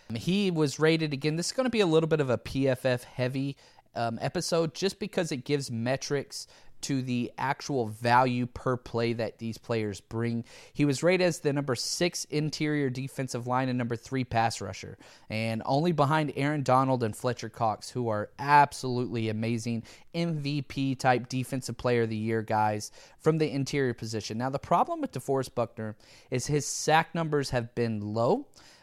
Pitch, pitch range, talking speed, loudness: 130 Hz, 115-150 Hz, 175 wpm, -29 LUFS